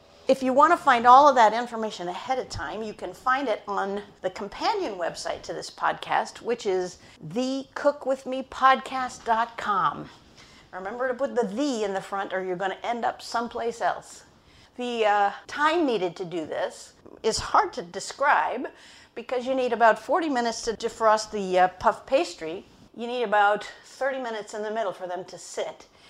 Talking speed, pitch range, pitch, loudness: 175 wpm, 200-260 Hz, 230 Hz, -25 LUFS